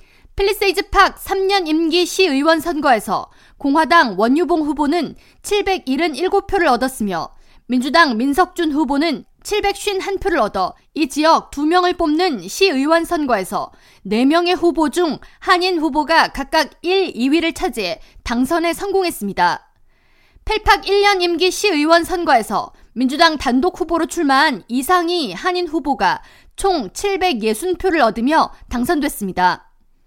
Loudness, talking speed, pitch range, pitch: -17 LUFS, 255 characters per minute, 285-370 Hz, 335 Hz